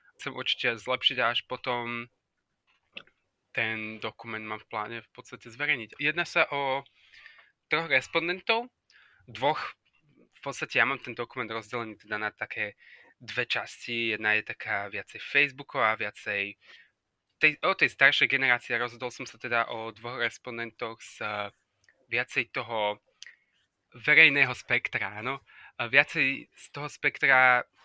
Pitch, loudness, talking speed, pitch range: 120 Hz, -27 LUFS, 135 wpm, 115-135 Hz